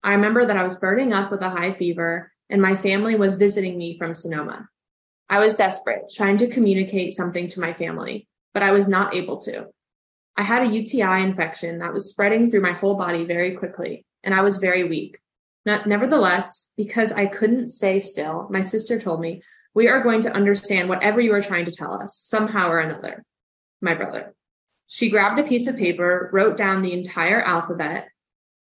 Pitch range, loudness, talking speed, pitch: 180-215 Hz, -21 LUFS, 195 wpm, 195 Hz